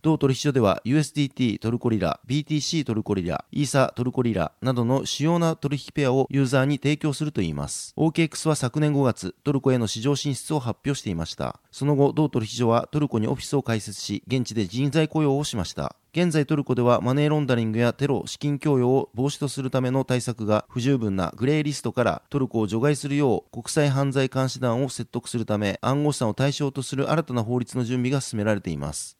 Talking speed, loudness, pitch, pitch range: 435 characters per minute, -24 LUFS, 130 Hz, 115-145 Hz